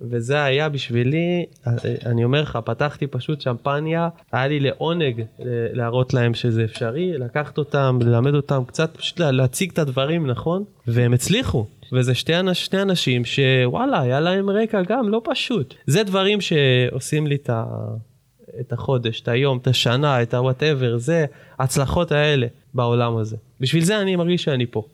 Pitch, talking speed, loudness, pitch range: 135 Hz, 150 wpm, -21 LUFS, 120-160 Hz